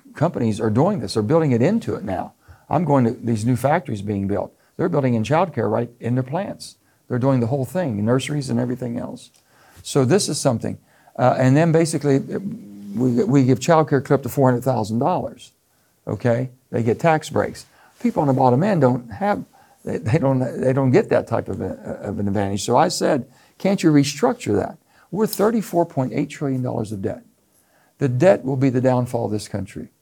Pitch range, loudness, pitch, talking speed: 115-150 Hz, -20 LUFS, 130 Hz, 190 wpm